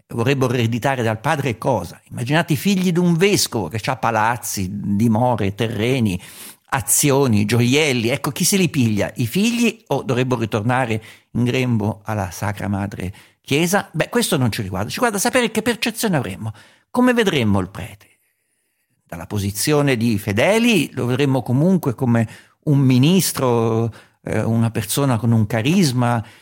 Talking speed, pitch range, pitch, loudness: 150 wpm, 110-150 Hz, 120 Hz, -19 LUFS